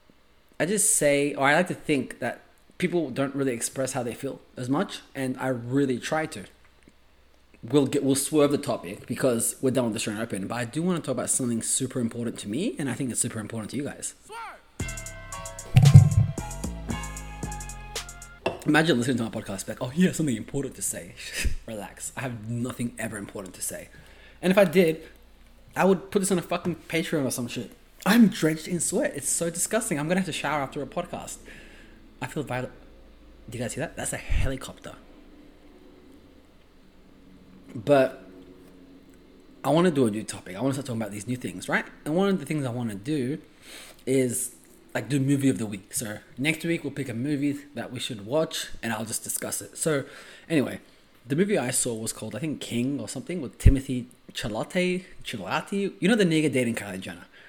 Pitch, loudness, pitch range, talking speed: 130 Hz, -26 LUFS, 115-155 Hz, 200 wpm